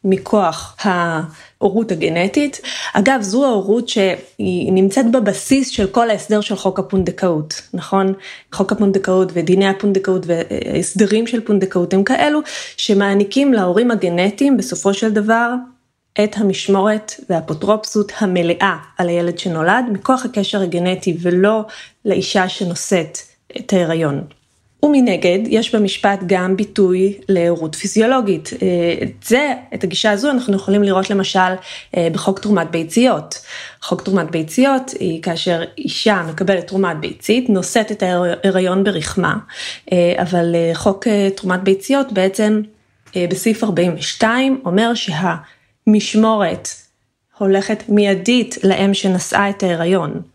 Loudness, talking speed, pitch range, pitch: -16 LUFS, 110 wpm, 180-215 Hz, 195 Hz